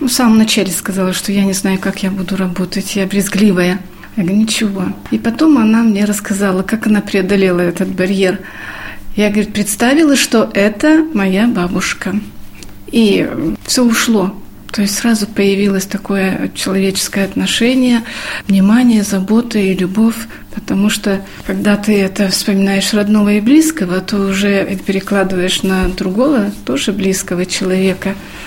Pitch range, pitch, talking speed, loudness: 190-215 Hz, 200 Hz, 140 wpm, -13 LUFS